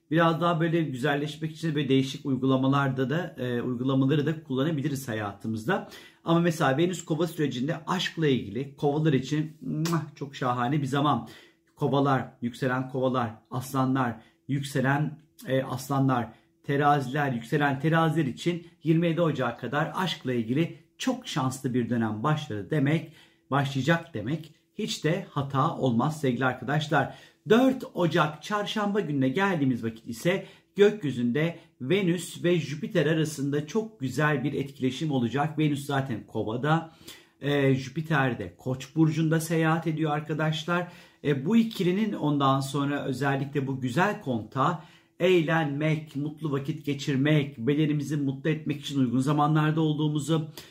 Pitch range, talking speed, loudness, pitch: 130-165 Hz, 125 wpm, -27 LUFS, 150 Hz